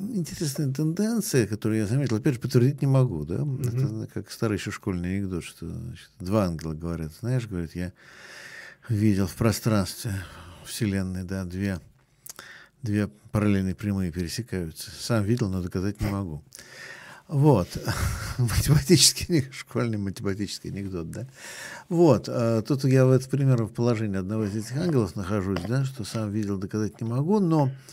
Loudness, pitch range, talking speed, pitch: -26 LUFS, 100-130 Hz, 145 wpm, 110 Hz